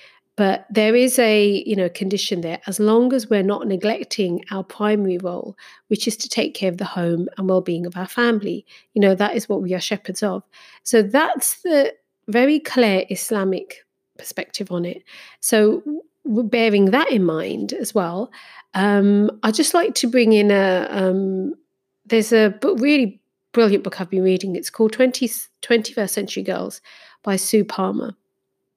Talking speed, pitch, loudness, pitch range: 175 wpm, 210 Hz, -19 LUFS, 190-235 Hz